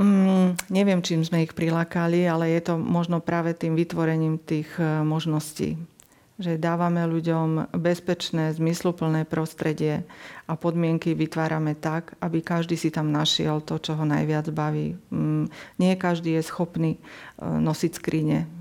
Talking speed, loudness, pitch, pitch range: 140 wpm, -25 LUFS, 165 Hz, 155-170 Hz